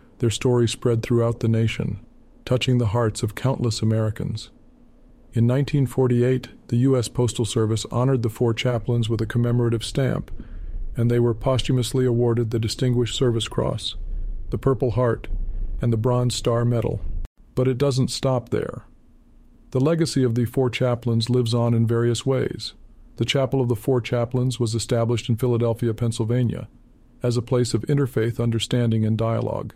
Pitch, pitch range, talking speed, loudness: 120 Hz, 115-125 Hz, 155 wpm, -22 LUFS